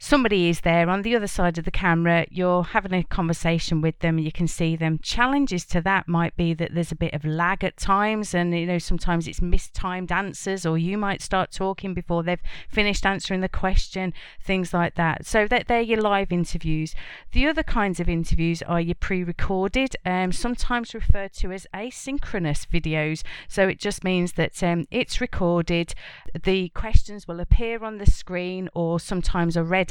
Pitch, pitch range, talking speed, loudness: 180 Hz, 170-195 Hz, 190 wpm, -24 LUFS